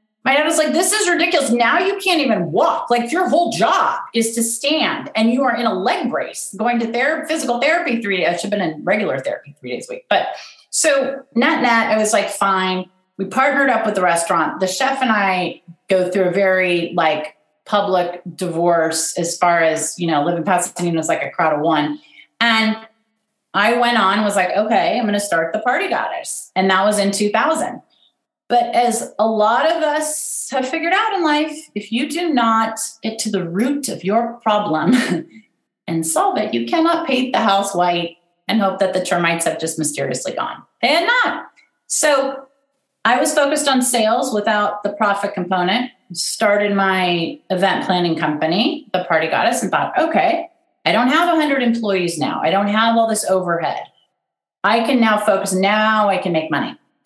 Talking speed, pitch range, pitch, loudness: 195 wpm, 185-270 Hz, 220 Hz, -17 LUFS